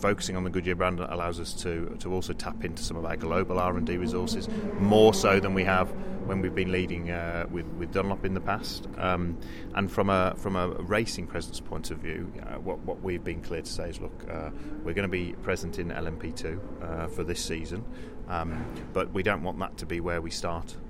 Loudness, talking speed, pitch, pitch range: -30 LUFS, 225 wpm, 90 Hz, 85-95 Hz